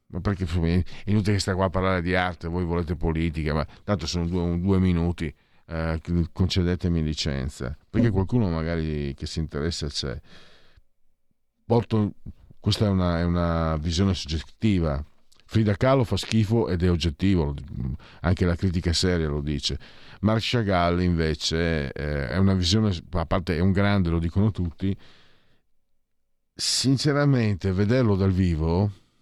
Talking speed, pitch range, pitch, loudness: 145 wpm, 80-100 Hz, 90 Hz, -25 LUFS